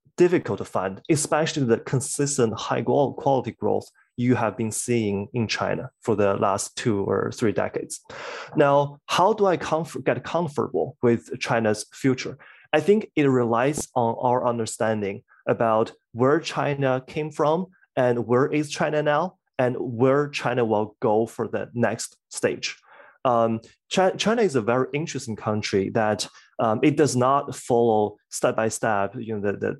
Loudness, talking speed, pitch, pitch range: -24 LUFS, 160 wpm, 125 Hz, 110-145 Hz